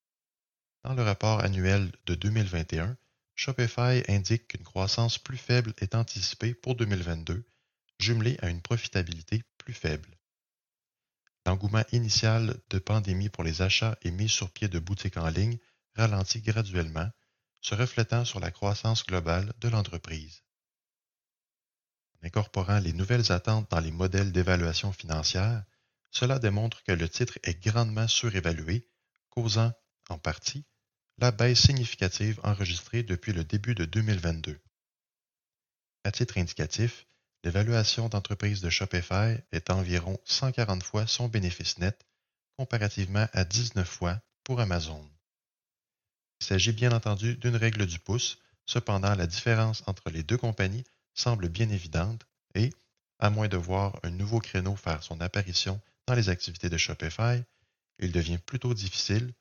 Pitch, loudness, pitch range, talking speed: 105 Hz, -29 LUFS, 90-115 Hz, 135 wpm